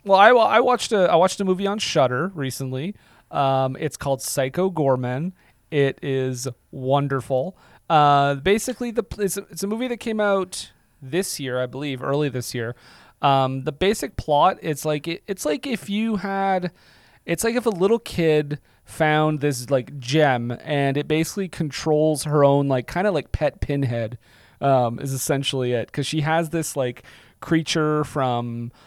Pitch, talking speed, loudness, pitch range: 150 Hz, 175 wpm, -22 LUFS, 130-185 Hz